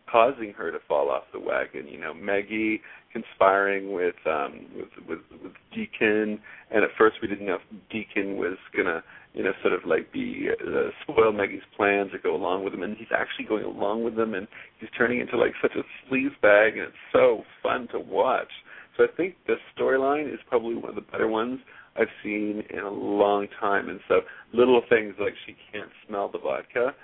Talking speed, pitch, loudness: 205 wpm, 125 Hz, -26 LUFS